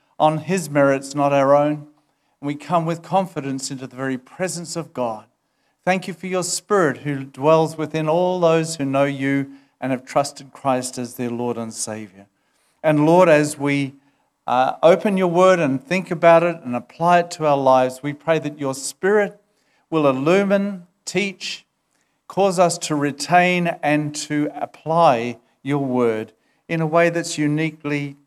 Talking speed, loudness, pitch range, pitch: 170 wpm, -20 LUFS, 135-175 Hz, 150 Hz